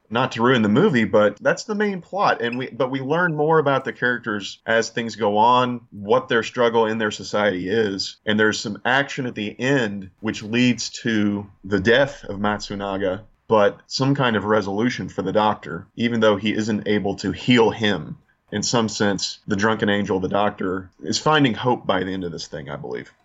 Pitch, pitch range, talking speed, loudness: 110 Hz, 100-125 Hz, 205 wpm, -21 LUFS